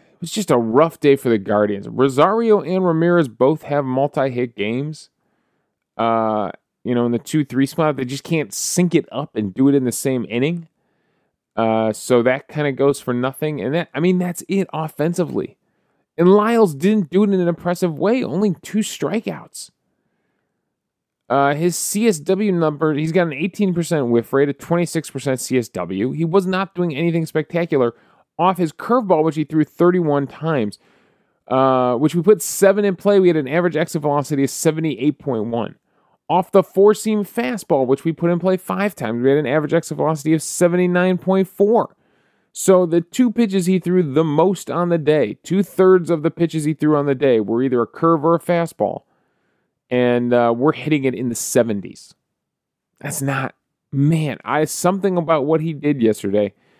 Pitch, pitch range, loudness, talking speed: 155 Hz, 135-180 Hz, -18 LUFS, 180 wpm